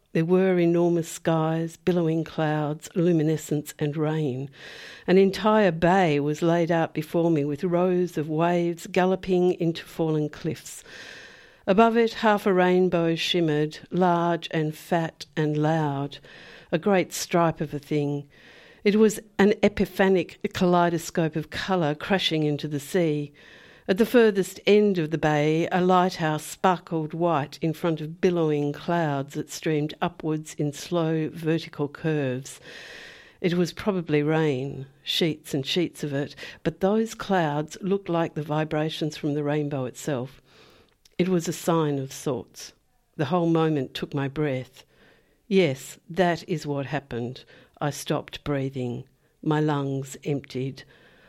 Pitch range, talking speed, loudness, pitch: 150-180 Hz, 140 wpm, -25 LUFS, 160 Hz